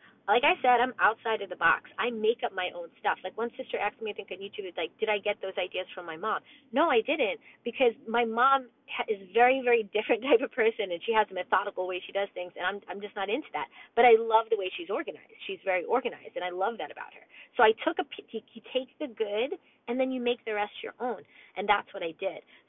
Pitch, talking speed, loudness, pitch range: 225 Hz, 265 wpm, -29 LUFS, 195-260 Hz